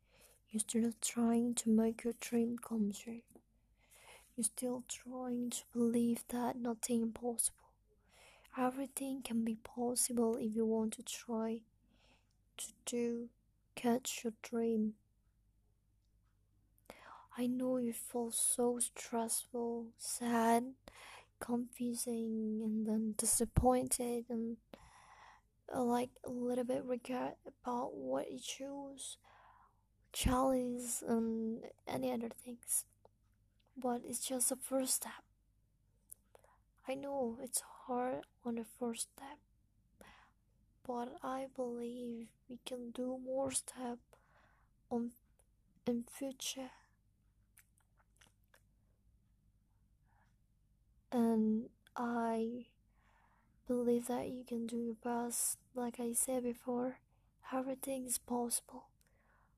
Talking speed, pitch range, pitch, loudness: 100 wpm, 220-250 Hz, 235 Hz, -39 LUFS